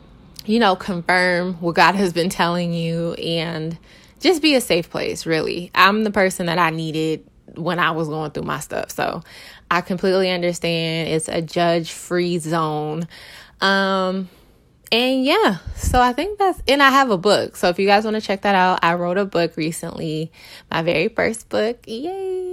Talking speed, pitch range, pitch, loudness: 180 wpm, 165-200 Hz, 180 Hz, -19 LUFS